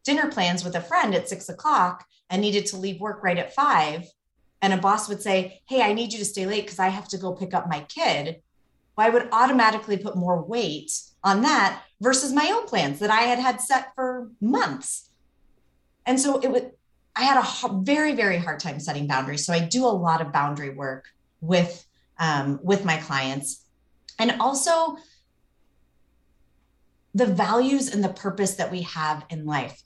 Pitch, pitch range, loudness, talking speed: 195 Hz, 165-245 Hz, -24 LUFS, 190 wpm